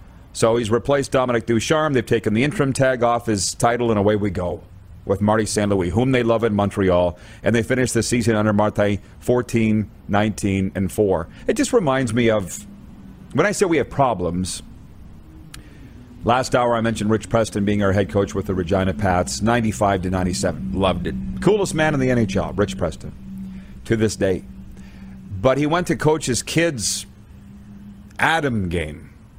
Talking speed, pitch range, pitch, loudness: 175 wpm, 95-120 Hz, 105 Hz, -20 LUFS